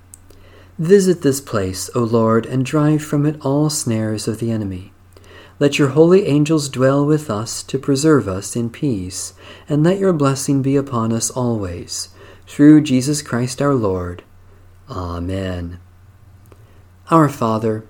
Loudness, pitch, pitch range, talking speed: -17 LUFS, 115 Hz, 95-145 Hz, 140 wpm